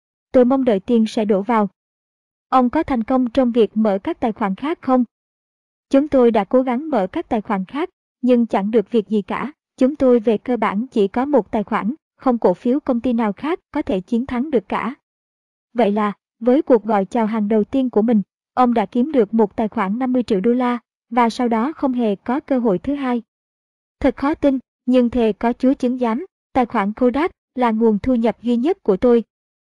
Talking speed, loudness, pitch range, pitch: 225 wpm, -19 LUFS, 220-260 Hz, 240 Hz